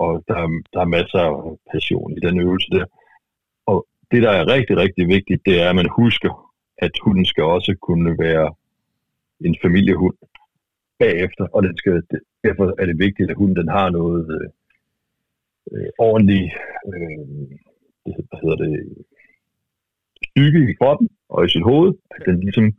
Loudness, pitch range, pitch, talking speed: -18 LUFS, 85-100 Hz, 90 Hz, 155 wpm